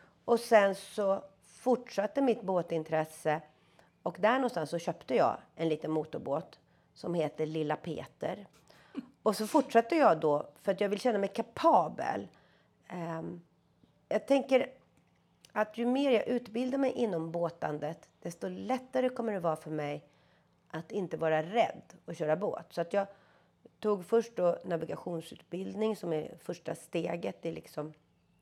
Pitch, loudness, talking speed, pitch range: 180 Hz, -32 LUFS, 145 wpm, 160-230 Hz